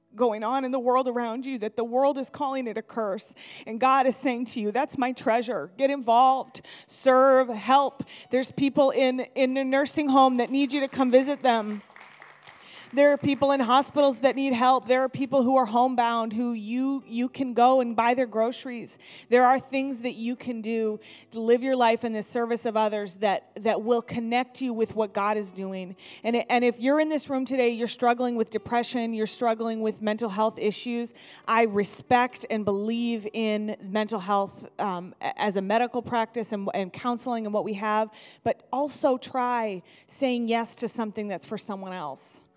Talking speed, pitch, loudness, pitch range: 195 wpm, 240 Hz, -25 LUFS, 220-260 Hz